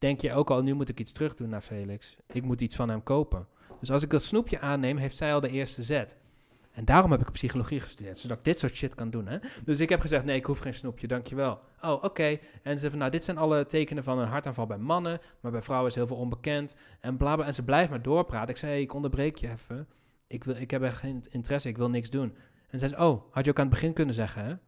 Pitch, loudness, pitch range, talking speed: 135 Hz, -30 LUFS, 120-145 Hz, 275 wpm